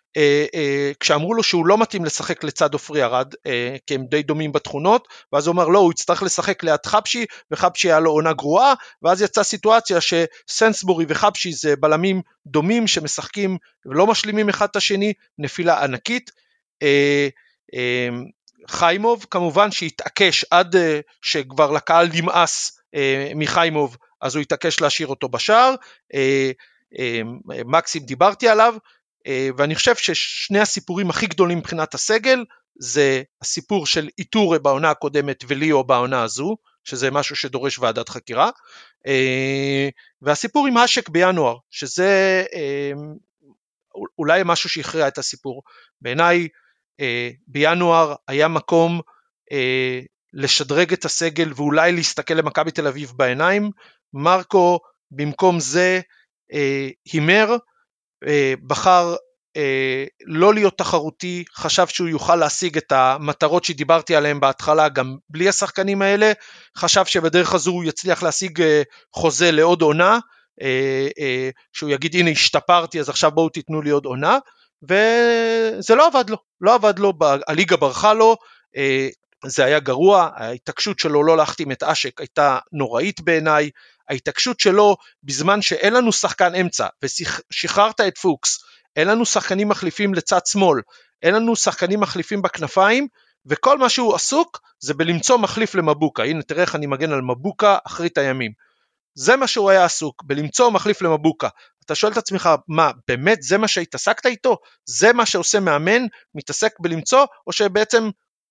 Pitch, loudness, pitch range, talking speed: 170 Hz, -18 LUFS, 145-200 Hz, 135 wpm